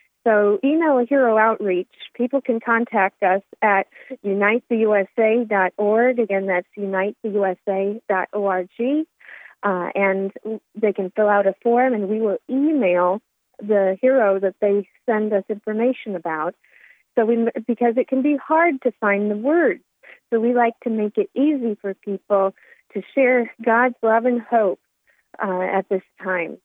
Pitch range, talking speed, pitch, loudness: 195-240 Hz, 140 wpm, 215 Hz, -20 LUFS